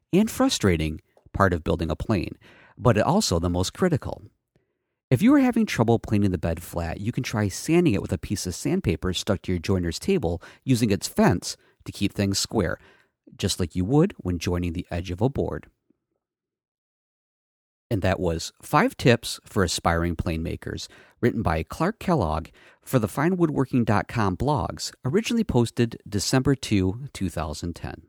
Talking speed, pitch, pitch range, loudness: 160 wpm, 100 Hz, 85-120 Hz, -24 LUFS